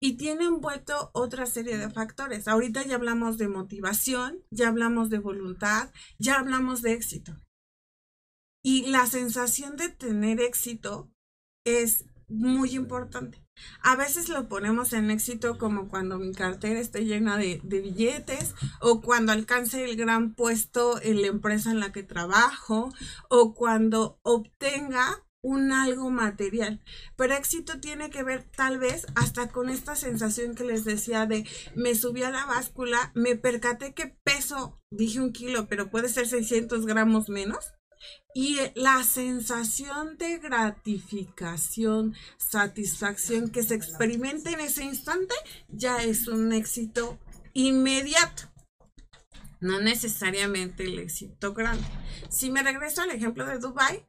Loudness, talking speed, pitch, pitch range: -27 LUFS, 140 wpm, 235 Hz, 220-260 Hz